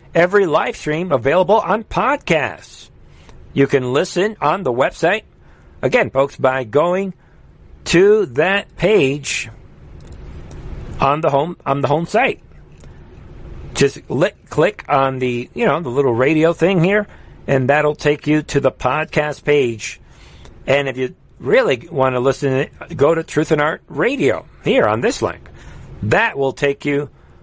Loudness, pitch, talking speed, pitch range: -17 LUFS, 140 Hz, 145 wpm, 120-160 Hz